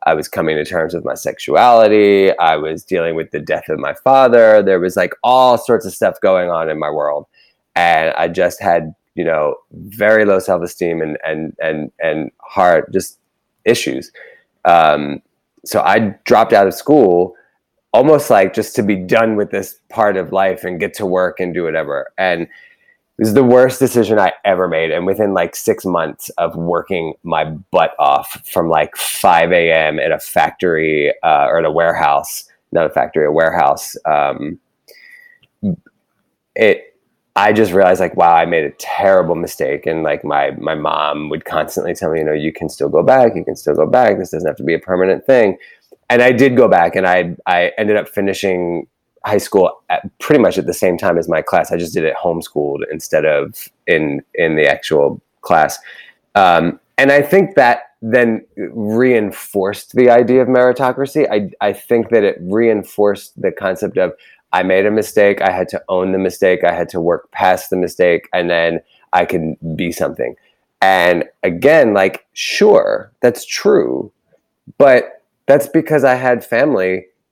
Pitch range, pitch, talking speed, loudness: 85-125 Hz, 100 Hz, 185 wpm, -14 LUFS